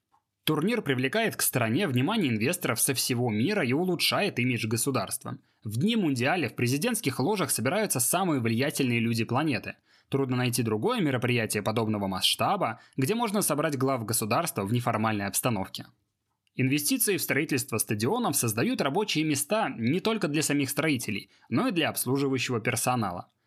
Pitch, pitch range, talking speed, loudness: 130 Hz, 115-150 Hz, 140 wpm, -27 LUFS